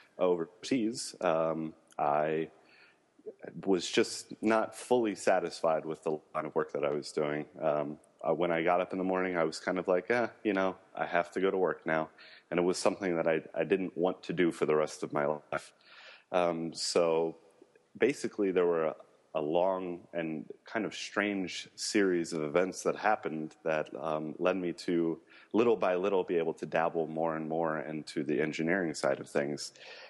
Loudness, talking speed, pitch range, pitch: -32 LUFS, 190 wpm, 80-90 Hz, 80 Hz